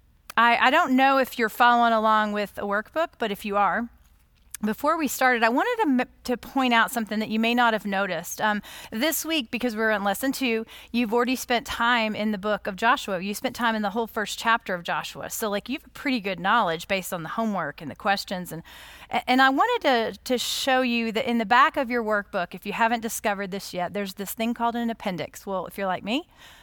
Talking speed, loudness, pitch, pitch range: 235 wpm, -24 LUFS, 230 Hz, 205-250 Hz